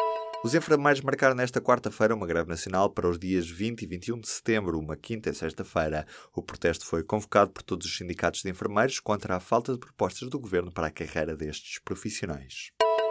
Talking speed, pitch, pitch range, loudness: 190 wpm, 105 Hz, 85-115 Hz, -29 LUFS